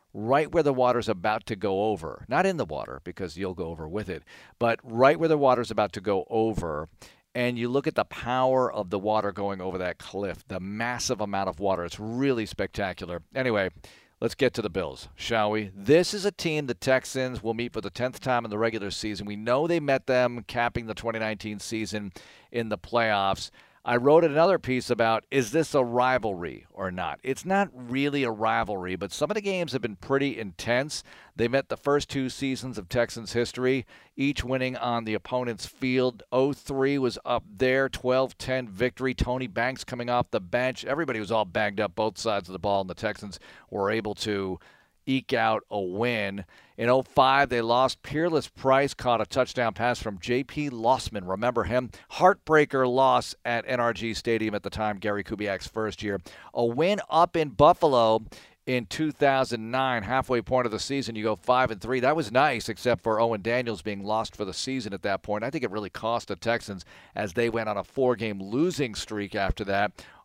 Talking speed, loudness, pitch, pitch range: 200 wpm, -27 LUFS, 120 Hz, 105-130 Hz